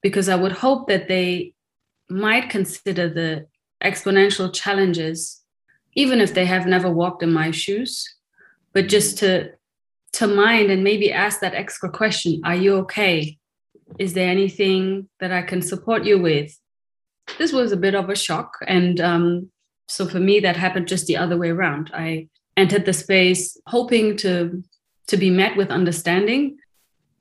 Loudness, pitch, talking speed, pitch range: -19 LUFS, 190 Hz, 160 wpm, 175-200 Hz